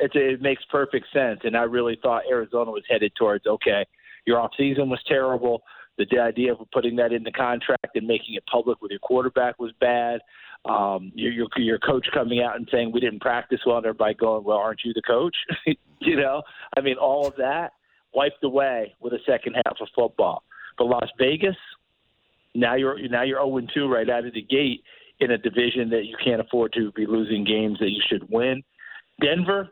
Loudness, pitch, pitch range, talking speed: -24 LUFS, 120 Hz, 115-135 Hz, 210 wpm